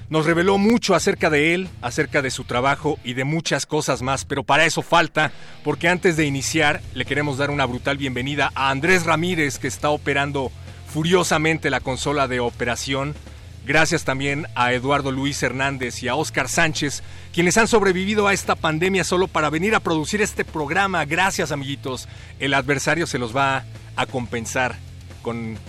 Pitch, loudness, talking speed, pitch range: 140 Hz, -20 LUFS, 170 wpm, 125-160 Hz